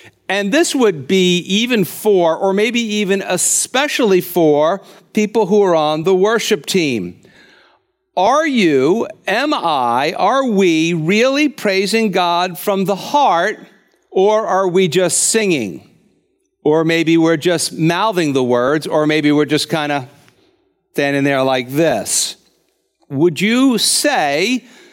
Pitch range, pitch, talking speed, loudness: 165-220 Hz, 190 Hz, 130 wpm, -15 LUFS